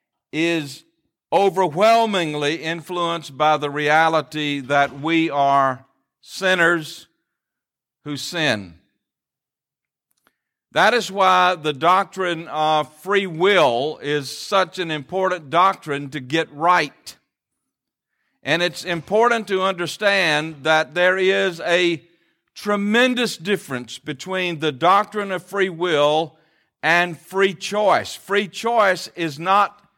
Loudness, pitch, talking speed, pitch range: -19 LUFS, 170 Hz, 105 wpm, 150-190 Hz